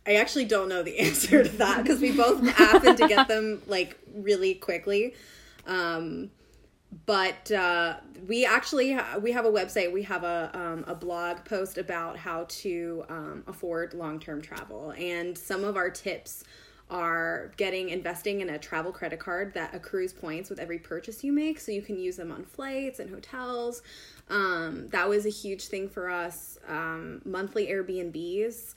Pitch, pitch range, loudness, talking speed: 190 Hz, 175-225 Hz, -27 LUFS, 175 wpm